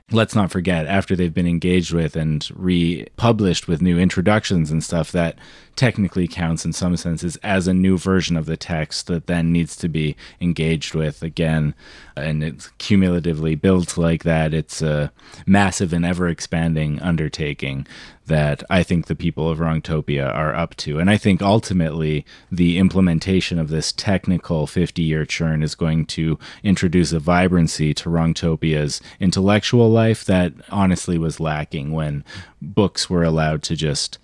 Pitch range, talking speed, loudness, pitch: 80-90 Hz, 160 wpm, -20 LUFS, 85 Hz